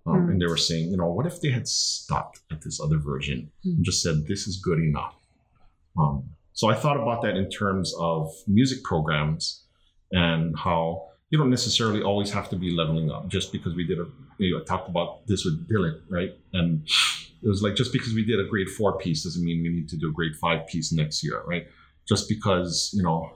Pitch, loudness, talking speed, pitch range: 90 Hz, -25 LUFS, 225 wpm, 80-105 Hz